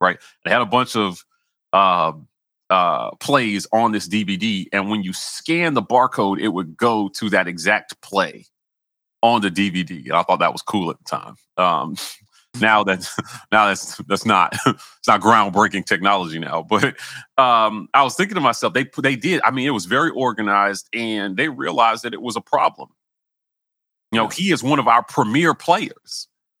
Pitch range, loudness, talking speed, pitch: 95-115 Hz, -19 LUFS, 185 wpm, 105 Hz